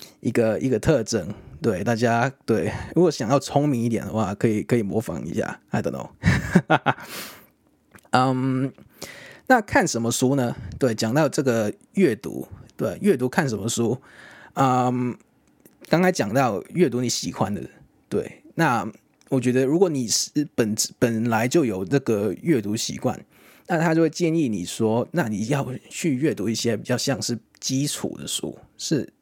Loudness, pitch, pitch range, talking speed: -23 LUFS, 125 Hz, 115-140 Hz, 240 characters per minute